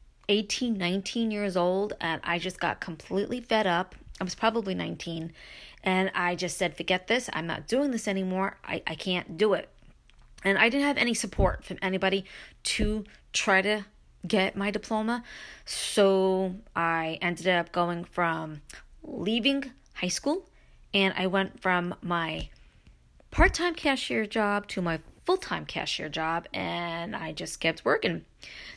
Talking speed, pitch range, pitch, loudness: 155 wpm, 175-220 Hz, 190 Hz, -28 LUFS